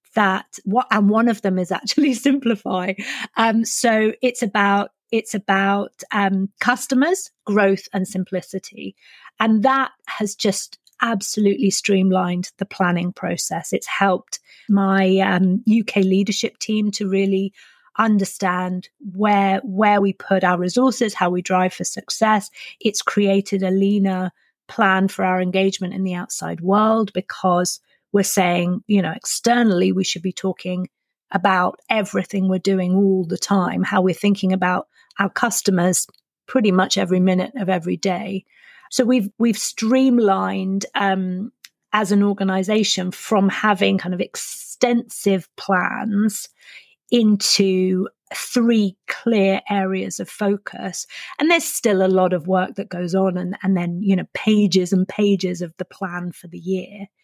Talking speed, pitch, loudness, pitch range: 145 wpm, 195 Hz, -19 LUFS, 185-215 Hz